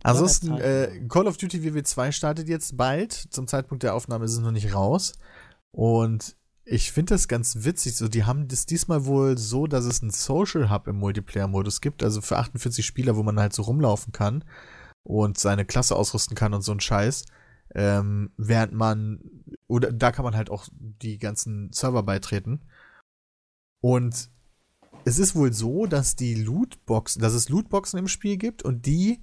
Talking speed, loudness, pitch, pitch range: 180 wpm, -25 LUFS, 120 Hz, 110-145 Hz